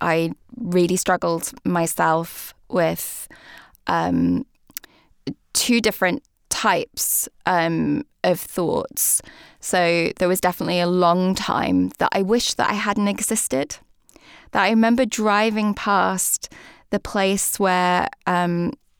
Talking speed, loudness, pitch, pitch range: 110 wpm, -20 LUFS, 185 Hz, 170-205 Hz